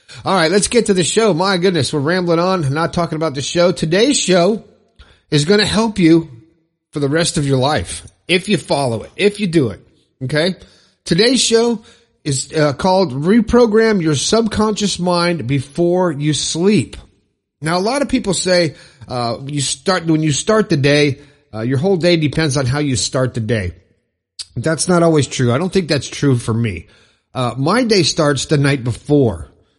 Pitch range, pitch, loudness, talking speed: 135-185 Hz, 160 Hz, -15 LUFS, 190 wpm